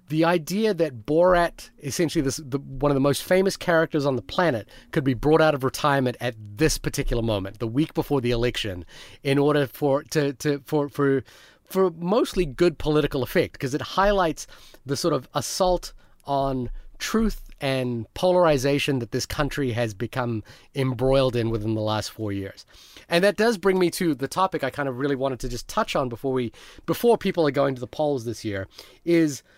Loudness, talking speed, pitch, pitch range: -24 LUFS, 195 wpm, 140 Hz, 125-160 Hz